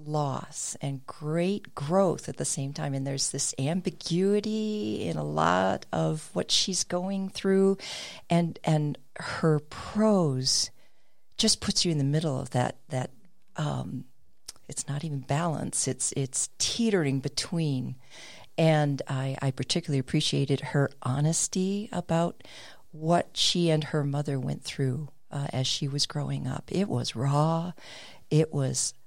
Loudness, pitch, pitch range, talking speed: -28 LUFS, 150 Hz, 135-170 Hz, 140 wpm